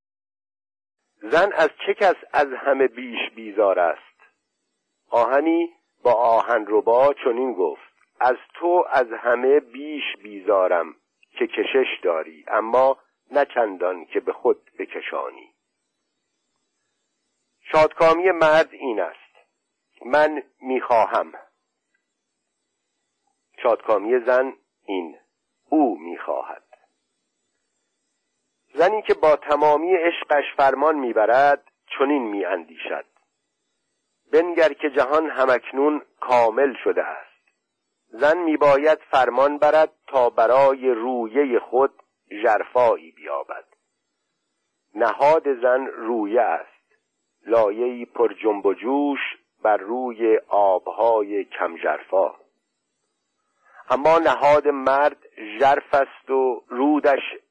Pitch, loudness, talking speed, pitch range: 145 Hz, -21 LUFS, 90 wpm, 125-165 Hz